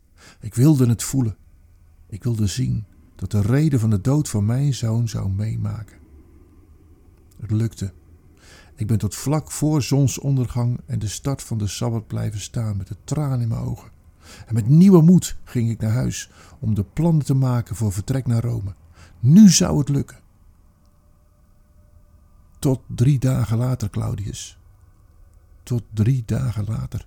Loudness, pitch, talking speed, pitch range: -20 LUFS, 110 Hz, 155 wpm, 90-125 Hz